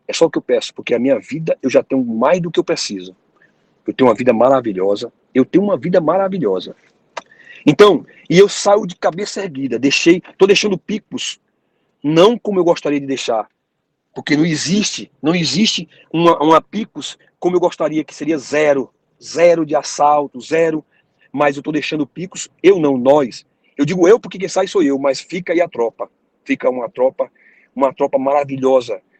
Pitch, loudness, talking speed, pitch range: 165 Hz, -16 LUFS, 185 wpm, 145-200 Hz